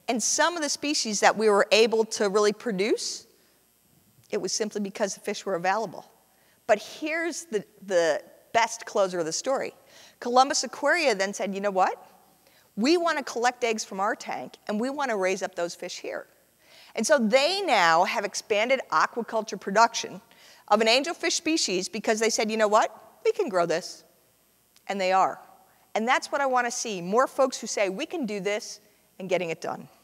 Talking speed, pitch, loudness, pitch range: 195 wpm, 225 Hz, -25 LUFS, 200-270 Hz